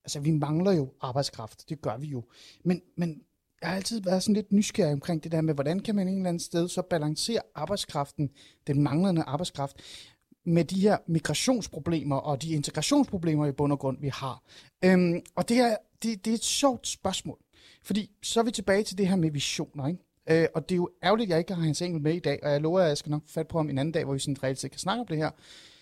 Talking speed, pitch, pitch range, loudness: 250 wpm, 160 Hz, 145-185 Hz, -28 LUFS